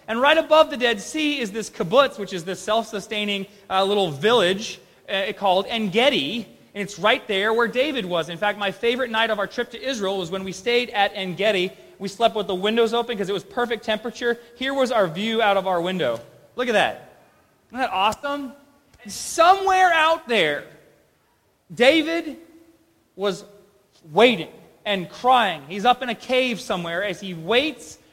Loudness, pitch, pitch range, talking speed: -21 LUFS, 220 Hz, 195-255 Hz, 185 wpm